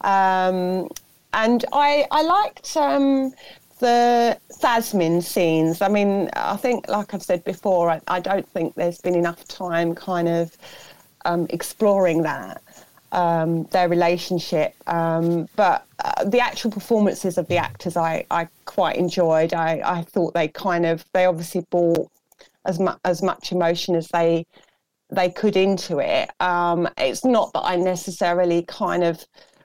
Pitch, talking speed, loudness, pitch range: 180 Hz, 150 wpm, -21 LUFS, 170-200 Hz